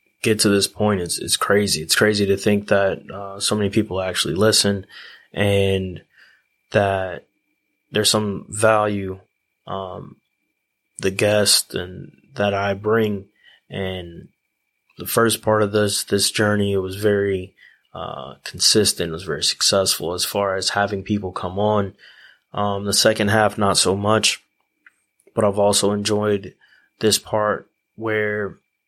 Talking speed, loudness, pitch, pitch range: 140 wpm, -19 LUFS, 100 Hz, 95-105 Hz